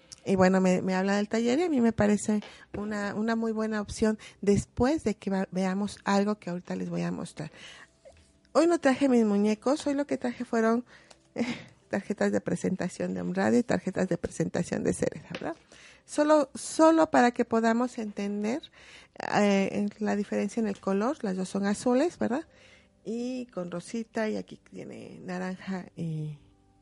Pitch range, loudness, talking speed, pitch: 190-235 Hz, -28 LUFS, 170 wpm, 210 Hz